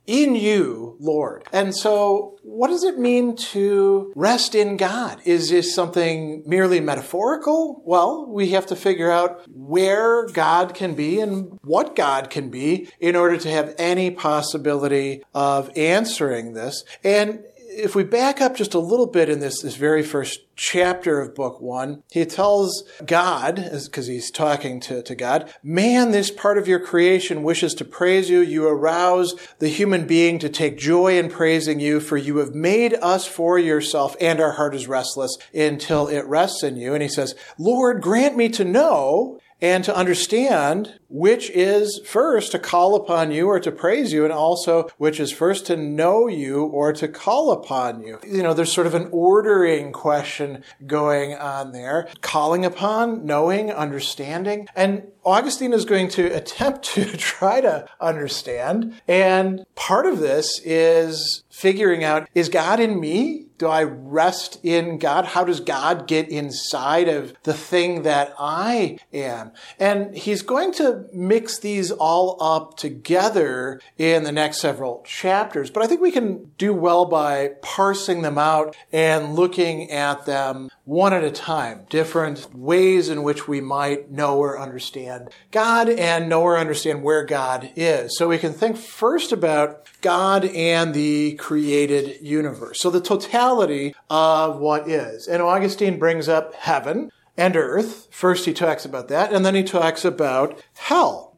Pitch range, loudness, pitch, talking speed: 150-195 Hz, -20 LUFS, 170 Hz, 165 wpm